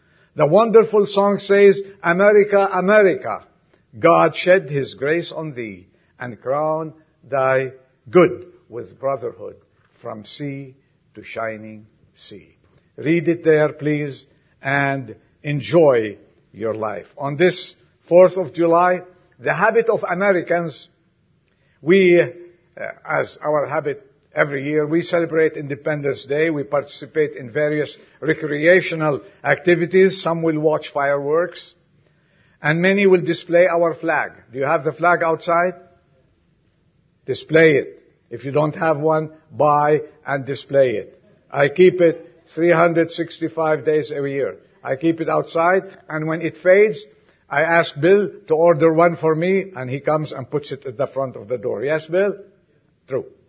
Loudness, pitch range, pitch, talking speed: -18 LUFS, 145-180 Hz, 160 Hz, 135 wpm